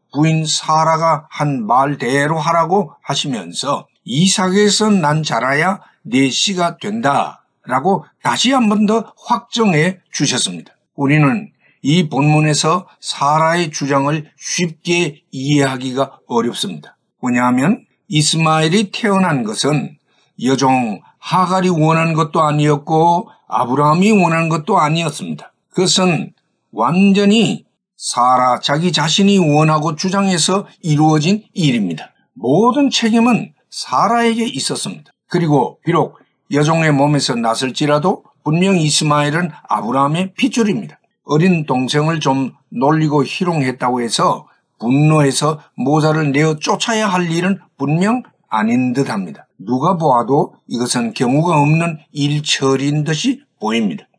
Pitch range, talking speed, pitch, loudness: 145-190 Hz, 275 characters per minute, 160 Hz, -15 LUFS